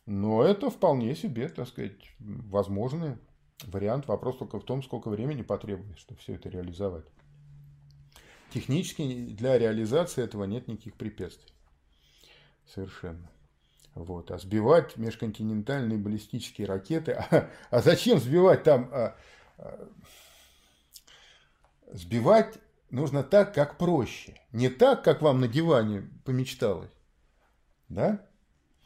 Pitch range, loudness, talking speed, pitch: 90-140 Hz, -27 LUFS, 110 wpm, 110 Hz